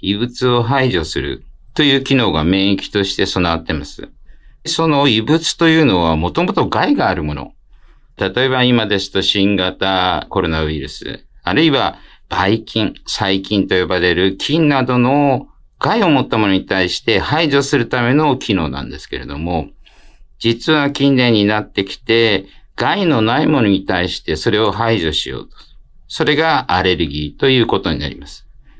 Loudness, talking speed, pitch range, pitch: -15 LUFS, 315 characters per minute, 90-135 Hz, 105 Hz